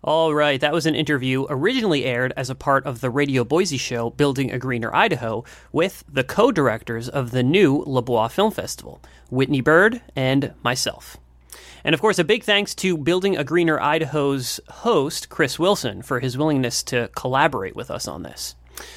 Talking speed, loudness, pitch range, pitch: 180 wpm, -21 LUFS, 125-155 Hz, 135 Hz